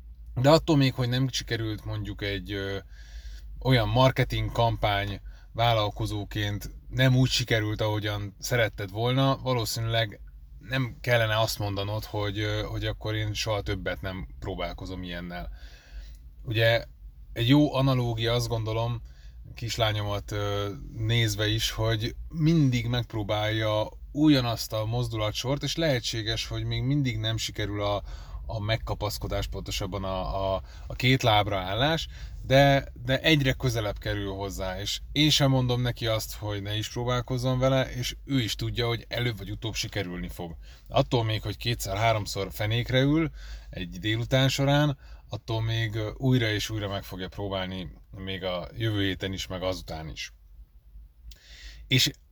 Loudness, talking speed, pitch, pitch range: -27 LUFS, 135 wpm, 110 Hz, 95-120 Hz